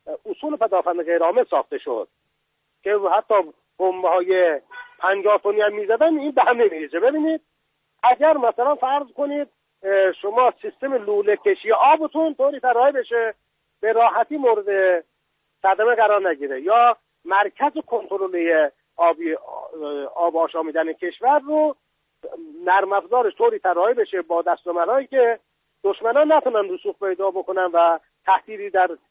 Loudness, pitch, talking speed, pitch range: -20 LUFS, 215 Hz, 120 wpm, 185-285 Hz